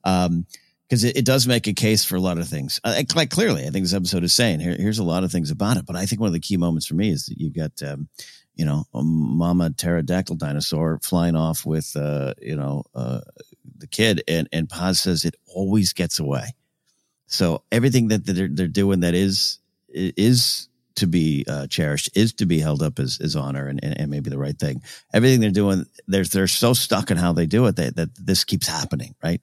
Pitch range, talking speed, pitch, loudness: 80-100 Hz, 230 wpm, 90 Hz, -21 LUFS